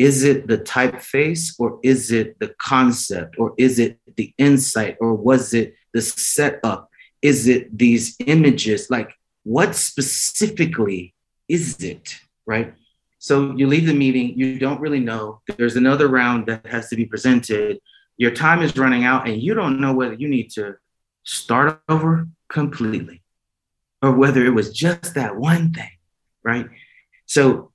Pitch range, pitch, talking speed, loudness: 115-145 Hz, 130 Hz, 155 wpm, -18 LUFS